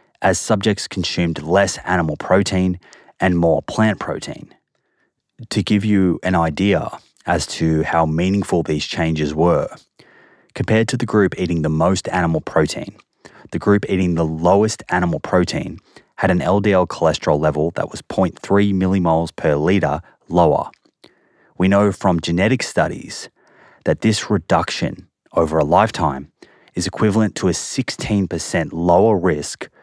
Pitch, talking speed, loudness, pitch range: 90 Hz, 135 wpm, -18 LUFS, 85-100 Hz